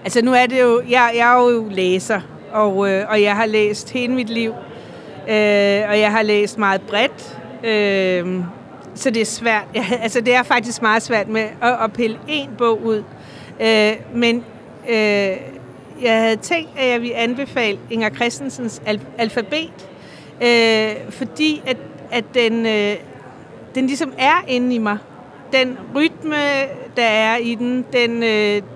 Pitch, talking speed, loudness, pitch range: 230 Hz, 165 wpm, -17 LUFS, 210-245 Hz